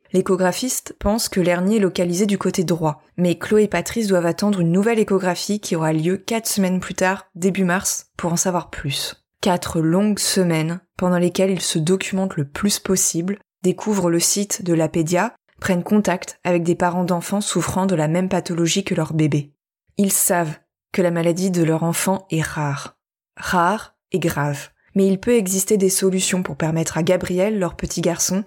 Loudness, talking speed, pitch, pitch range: -20 LUFS, 185 wpm, 180 Hz, 170-195 Hz